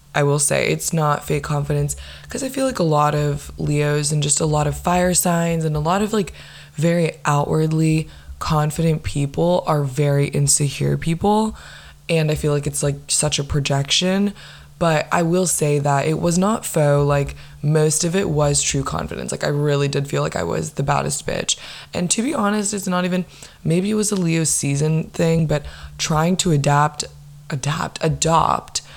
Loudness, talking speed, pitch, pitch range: -19 LUFS, 190 wpm, 150 Hz, 145-170 Hz